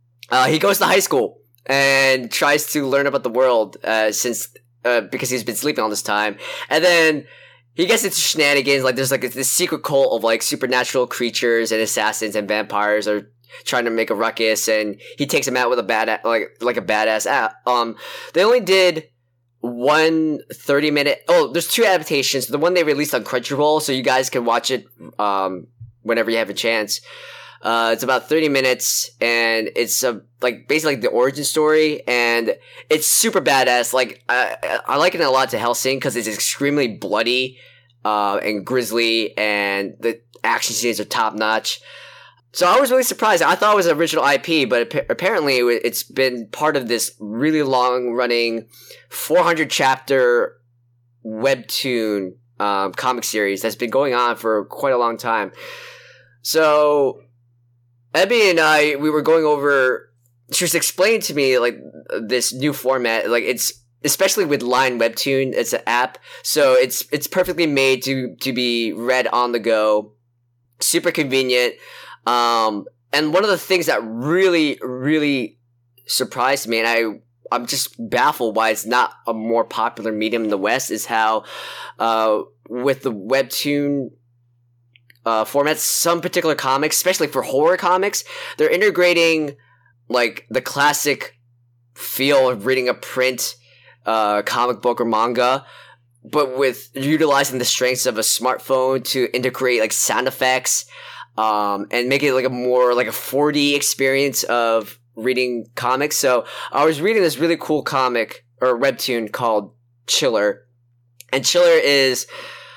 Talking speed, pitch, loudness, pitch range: 165 wpm, 125 Hz, -18 LUFS, 115-145 Hz